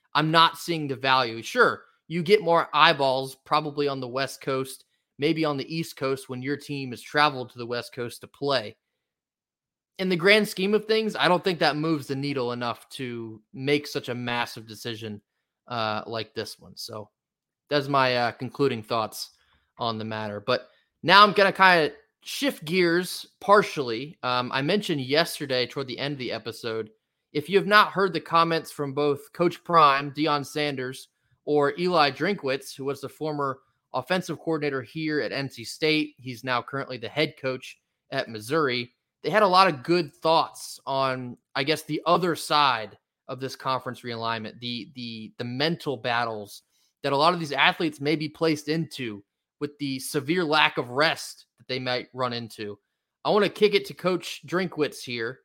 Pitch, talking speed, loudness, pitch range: 140 Hz, 185 wpm, -25 LUFS, 125-160 Hz